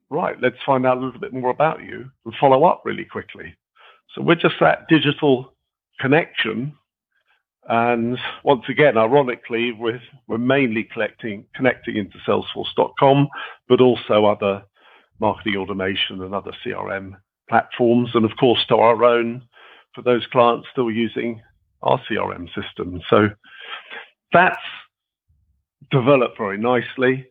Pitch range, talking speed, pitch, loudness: 110-130 Hz, 130 wpm, 120 Hz, -19 LUFS